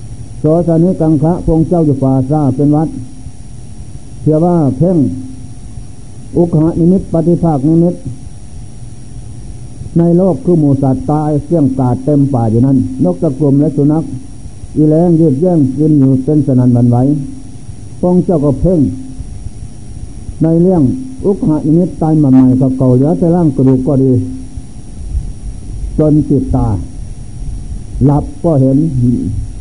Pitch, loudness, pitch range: 135 Hz, -11 LUFS, 120-155 Hz